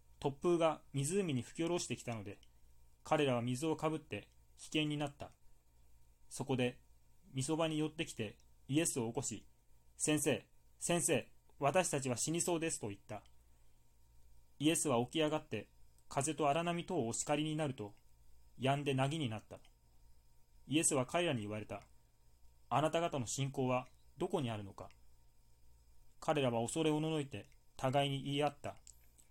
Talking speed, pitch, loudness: 295 characters per minute, 125 Hz, -37 LUFS